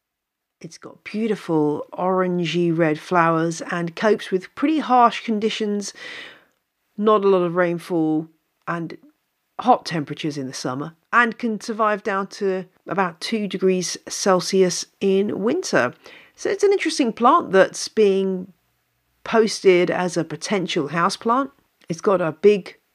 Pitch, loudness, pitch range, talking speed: 195 Hz, -21 LUFS, 175-225 Hz, 130 wpm